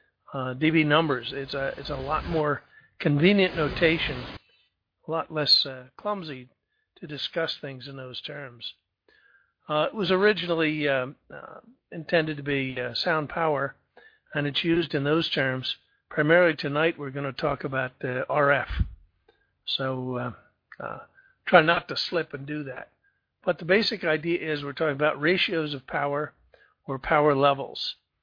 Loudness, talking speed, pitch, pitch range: -26 LUFS, 150 wpm, 150 Hz, 135-165 Hz